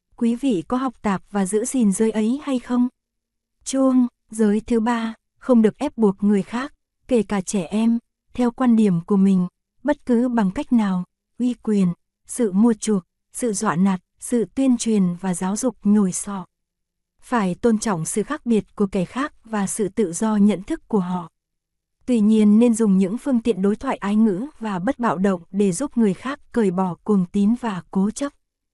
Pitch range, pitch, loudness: 200-240 Hz, 220 Hz, -21 LUFS